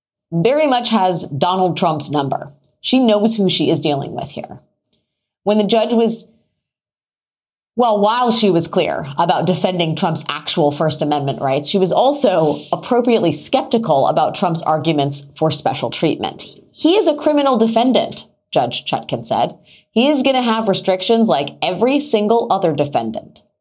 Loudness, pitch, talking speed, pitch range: -16 LUFS, 190 Hz, 155 wpm, 160-235 Hz